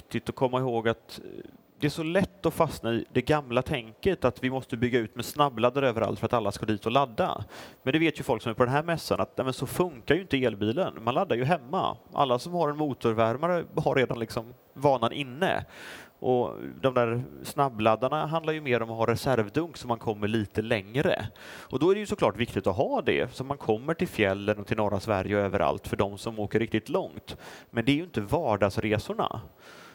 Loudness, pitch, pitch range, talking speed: -28 LUFS, 125 Hz, 115-145 Hz, 220 wpm